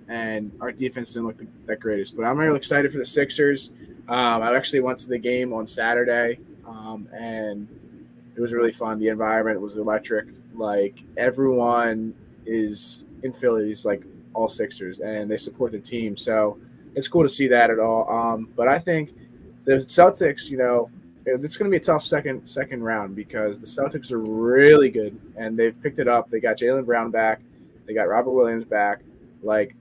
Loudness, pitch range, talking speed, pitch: -22 LUFS, 110-130 Hz, 185 wpm, 115 Hz